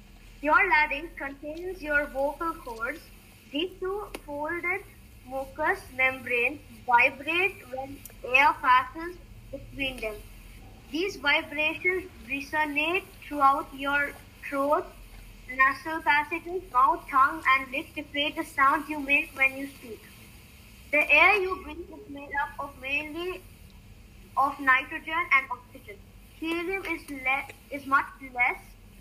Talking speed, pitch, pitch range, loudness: 120 wpm, 295 Hz, 275-335 Hz, -26 LUFS